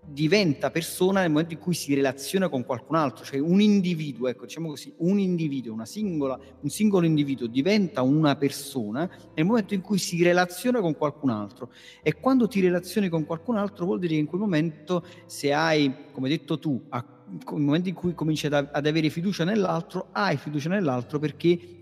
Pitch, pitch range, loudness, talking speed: 160 Hz, 140-180 Hz, -25 LUFS, 190 wpm